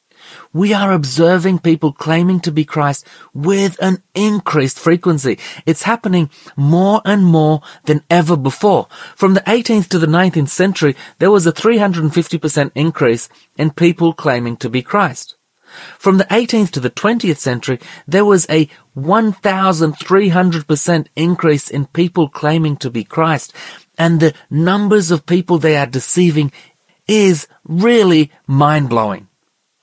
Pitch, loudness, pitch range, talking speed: 165 Hz, -14 LUFS, 150-190 Hz, 135 wpm